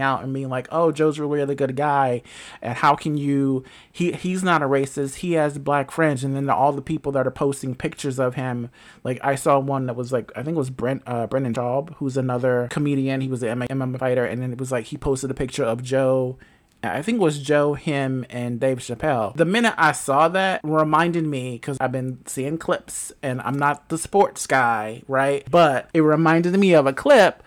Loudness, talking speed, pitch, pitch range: -22 LUFS, 225 wpm, 140 Hz, 130-155 Hz